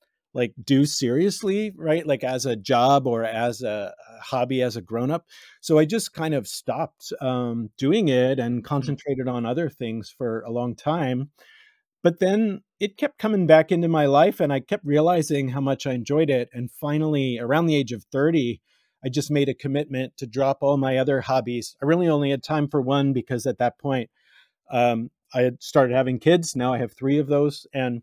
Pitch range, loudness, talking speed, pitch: 125-155 Hz, -23 LUFS, 200 wpm, 135 Hz